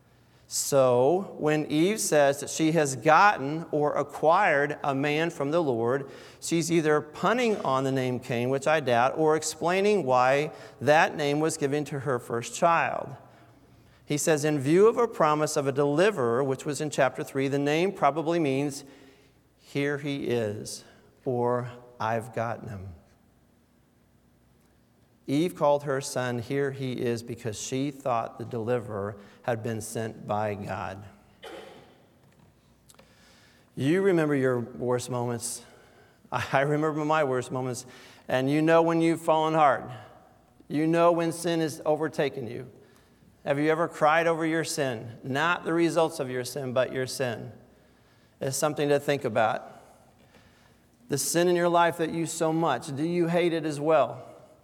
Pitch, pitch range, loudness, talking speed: 145 Hz, 125-160 Hz, -26 LUFS, 155 wpm